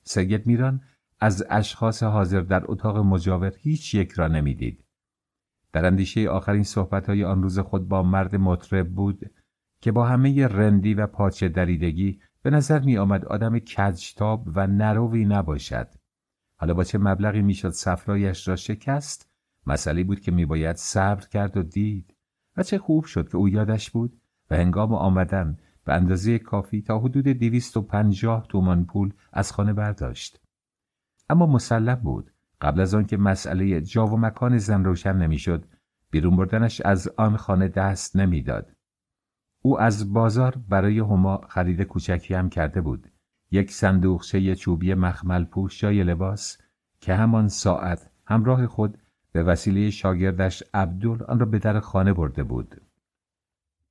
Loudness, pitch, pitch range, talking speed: -23 LUFS, 100 Hz, 90-110 Hz, 145 wpm